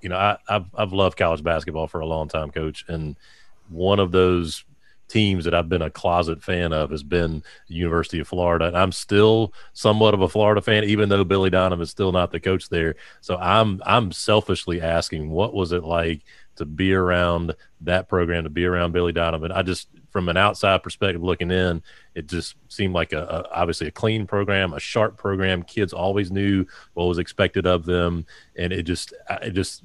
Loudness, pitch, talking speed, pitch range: -22 LUFS, 90 Hz, 205 wpm, 85-95 Hz